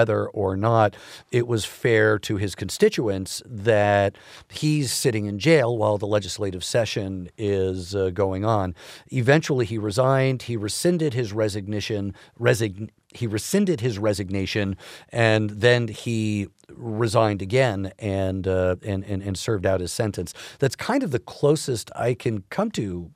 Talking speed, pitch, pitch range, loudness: 150 wpm, 110 Hz, 100-120 Hz, -23 LUFS